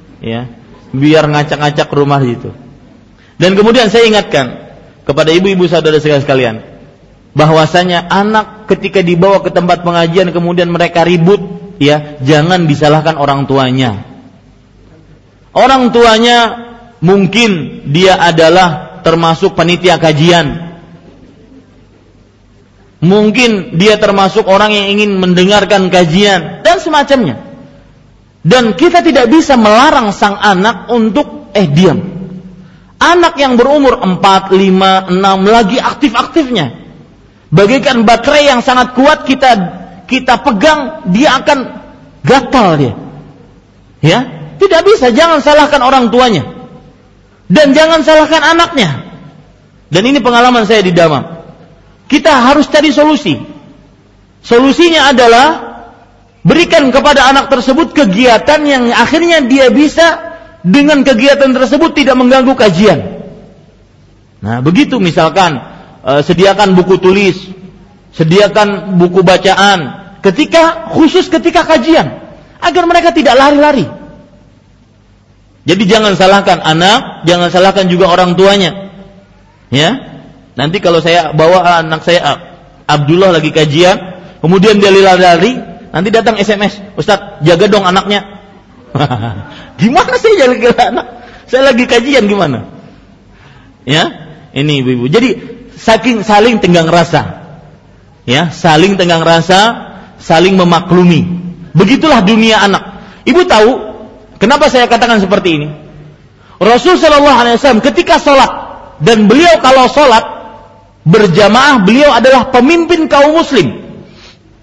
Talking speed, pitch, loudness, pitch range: 110 wpm, 195 Hz, -7 LUFS, 165-255 Hz